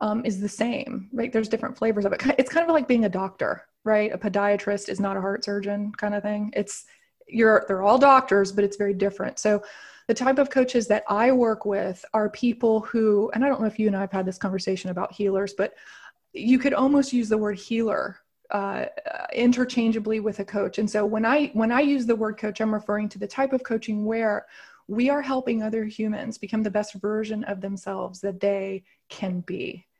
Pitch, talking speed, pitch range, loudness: 215 Hz, 220 wpm, 205-240 Hz, -24 LUFS